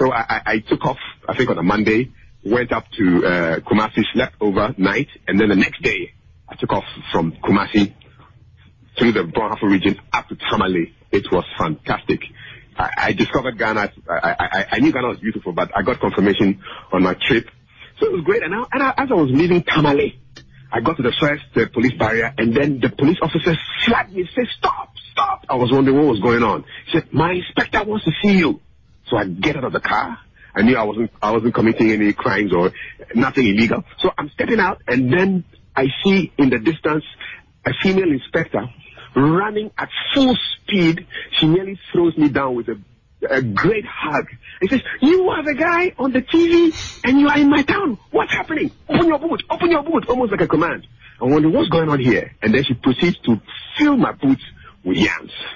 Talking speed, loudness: 205 wpm, -18 LUFS